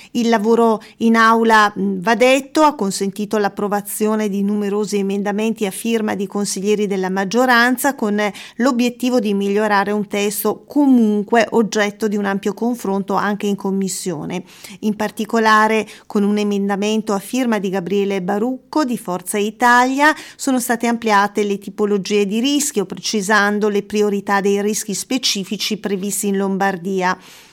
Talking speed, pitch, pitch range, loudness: 135 wpm, 210 Hz, 200-230 Hz, -17 LUFS